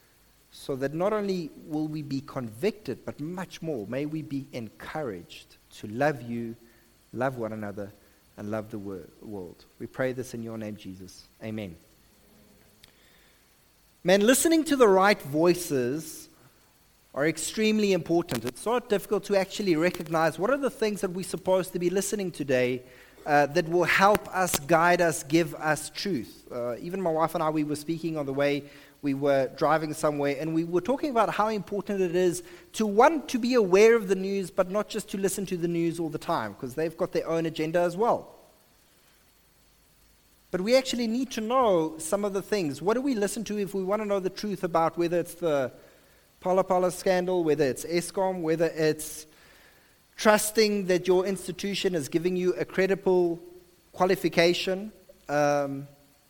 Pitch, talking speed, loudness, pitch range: 170 Hz, 175 wpm, -27 LUFS, 145-195 Hz